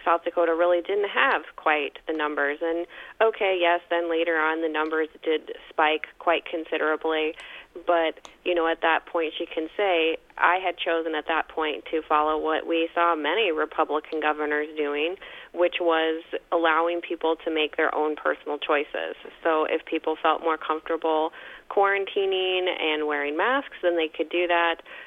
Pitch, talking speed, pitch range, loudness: 165 Hz, 165 wpm, 155-175 Hz, -25 LUFS